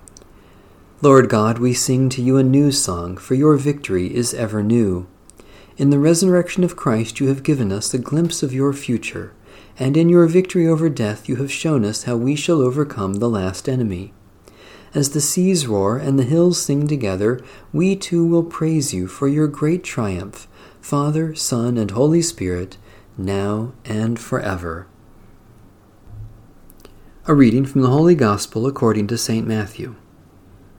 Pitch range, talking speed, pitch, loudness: 100-145 Hz, 160 wpm, 120 Hz, -18 LUFS